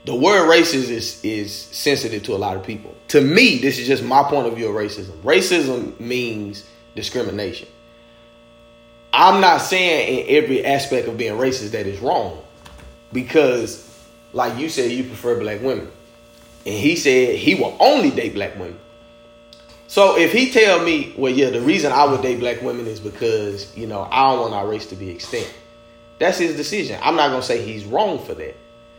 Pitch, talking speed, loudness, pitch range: 115 Hz, 190 wpm, -18 LUFS, 115-140 Hz